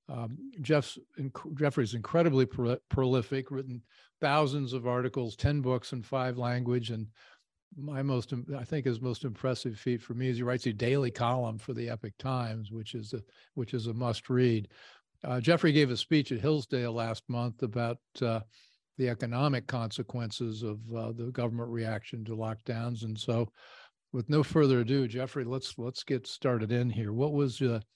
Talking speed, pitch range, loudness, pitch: 175 wpm, 115-135 Hz, -32 LUFS, 125 Hz